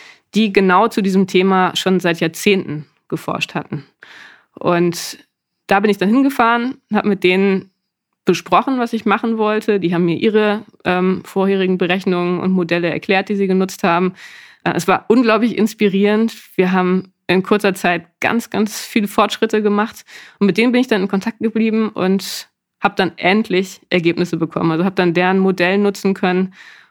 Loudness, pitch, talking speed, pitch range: -16 LUFS, 195 Hz, 165 wpm, 180-215 Hz